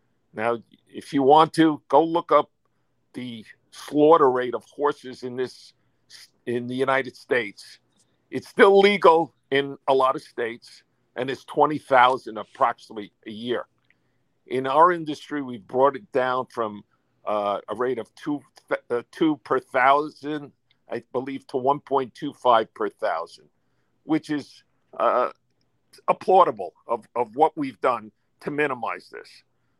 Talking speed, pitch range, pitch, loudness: 145 wpm, 125-150 Hz, 135 Hz, -23 LUFS